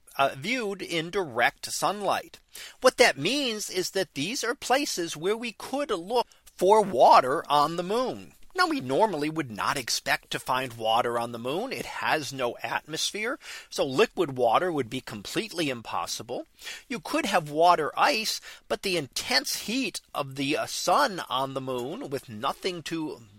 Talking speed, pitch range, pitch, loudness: 165 wpm, 135-205 Hz, 160 Hz, -27 LUFS